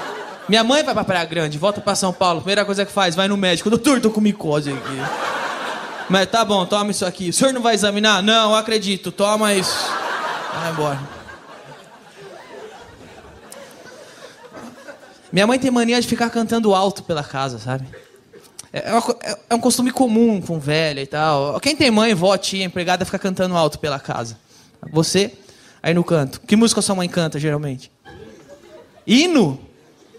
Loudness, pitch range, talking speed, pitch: -18 LUFS, 160-220 Hz, 165 wpm, 195 Hz